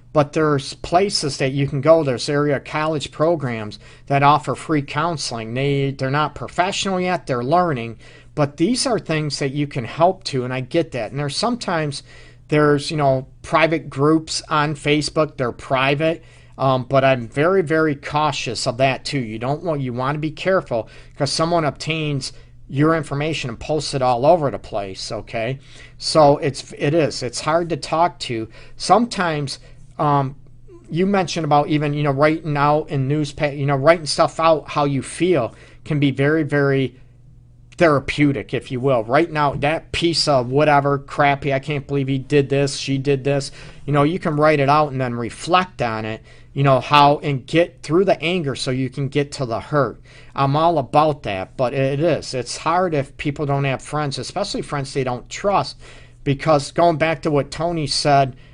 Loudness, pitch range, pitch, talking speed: -19 LUFS, 130-155 Hz, 140 Hz, 190 wpm